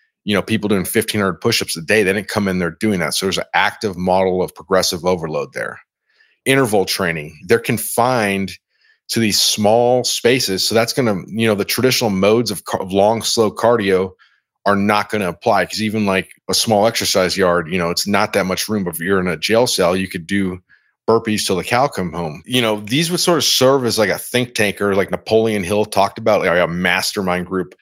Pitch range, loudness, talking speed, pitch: 95-115 Hz, -17 LUFS, 205 wpm, 105 Hz